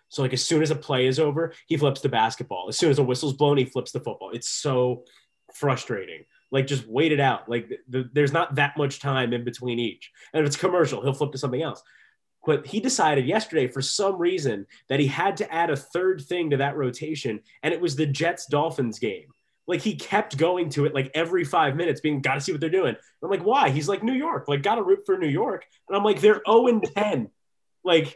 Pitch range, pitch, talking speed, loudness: 135-175 Hz, 145 Hz, 240 wpm, -24 LUFS